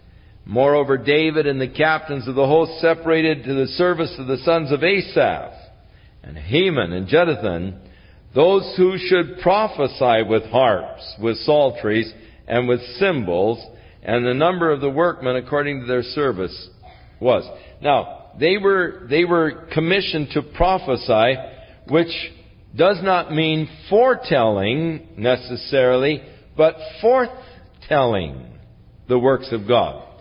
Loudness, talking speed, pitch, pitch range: -19 LUFS, 125 wpm, 140 Hz, 115-165 Hz